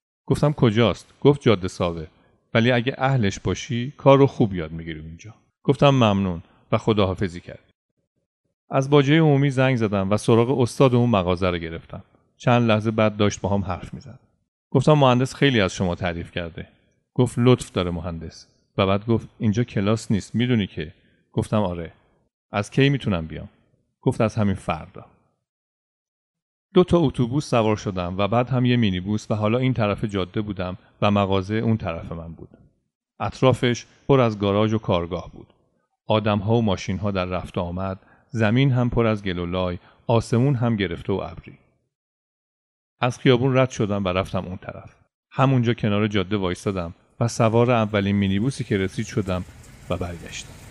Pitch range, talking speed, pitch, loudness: 95-125 Hz, 165 wpm, 110 Hz, -22 LUFS